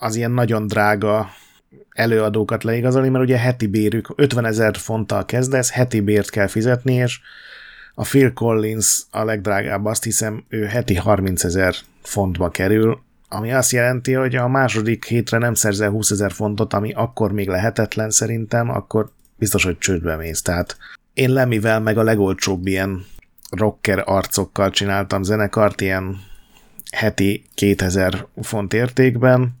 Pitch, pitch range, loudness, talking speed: 110 Hz, 100-115 Hz, -18 LUFS, 145 wpm